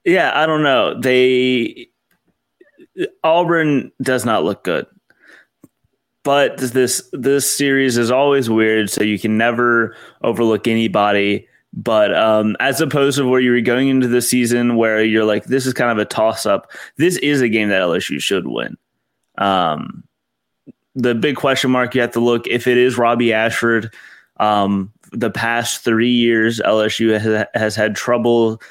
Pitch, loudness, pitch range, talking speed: 120 Hz, -16 LUFS, 110-130 Hz, 160 wpm